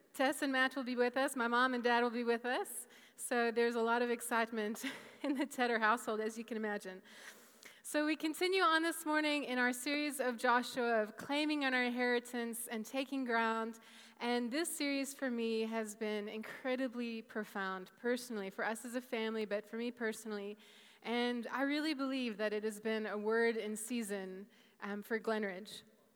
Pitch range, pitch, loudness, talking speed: 220-255 Hz, 235 Hz, -37 LUFS, 190 wpm